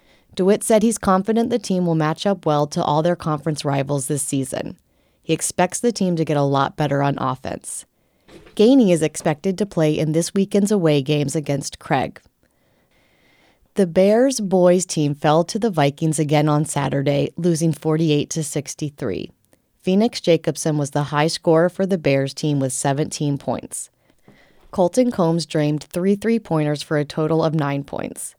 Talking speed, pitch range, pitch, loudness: 165 wpm, 145-185 Hz, 160 Hz, -20 LUFS